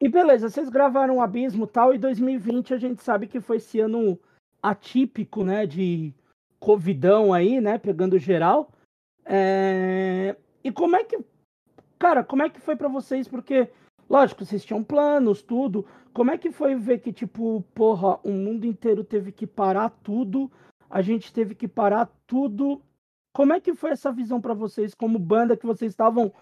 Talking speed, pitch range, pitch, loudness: 175 wpm, 210-265 Hz, 230 Hz, -23 LUFS